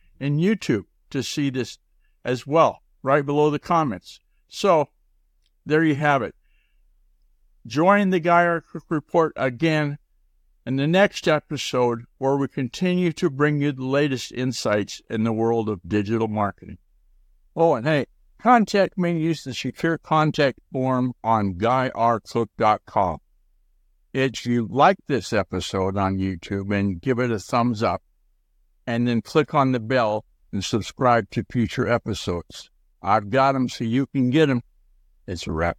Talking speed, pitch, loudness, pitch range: 150 wpm, 125 Hz, -22 LUFS, 105-150 Hz